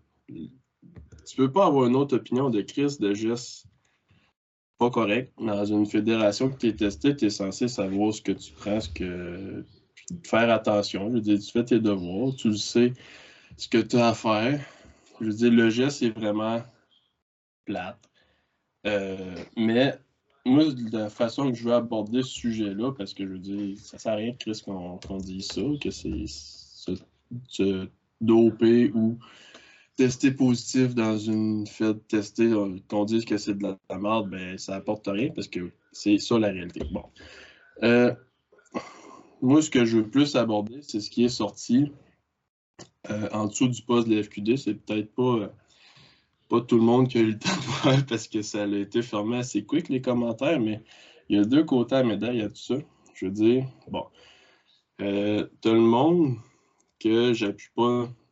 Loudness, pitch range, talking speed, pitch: -25 LUFS, 105-120 Hz, 190 wpm, 110 Hz